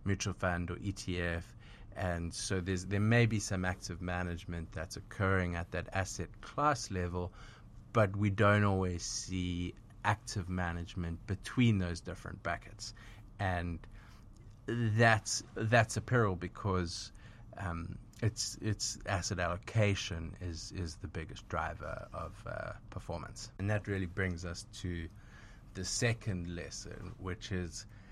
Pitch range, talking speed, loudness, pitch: 90-110 Hz, 130 wpm, -36 LUFS, 100 Hz